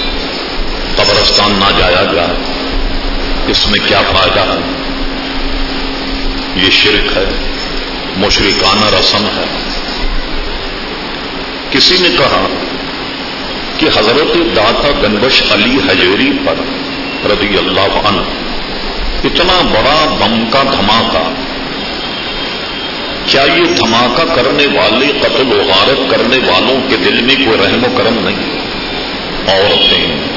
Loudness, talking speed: -10 LUFS, 105 wpm